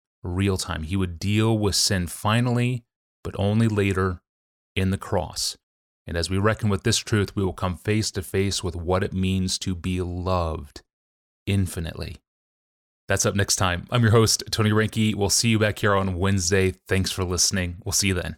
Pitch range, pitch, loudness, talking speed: 90-105 Hz, 95 Hz, -23 LUFS, 190 wpm